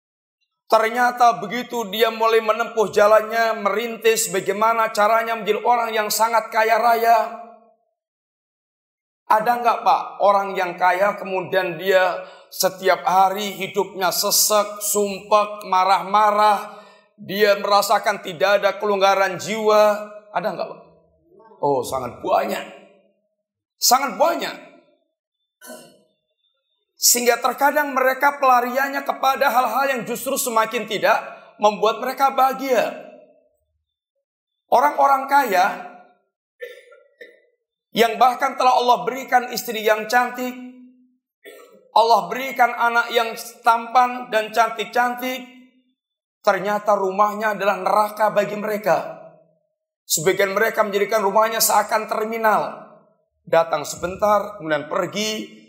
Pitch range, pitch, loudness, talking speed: 205-250 Hz, 225 Hz, -19 LUFS, 95 wpm